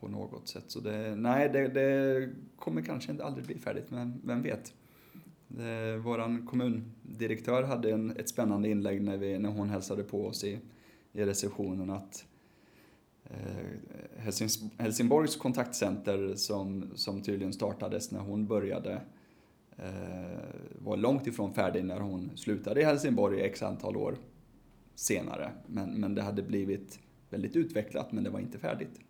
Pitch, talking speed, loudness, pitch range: 105 Hz, 150 wpm, -34 LUFS, 100-120 Hz